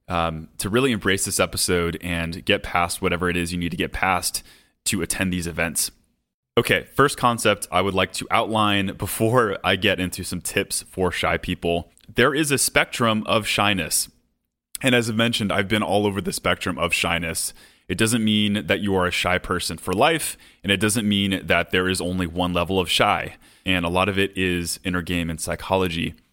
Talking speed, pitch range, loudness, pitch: 205 wpm, 85-105 Hz, -22 LUFS, 95 Hz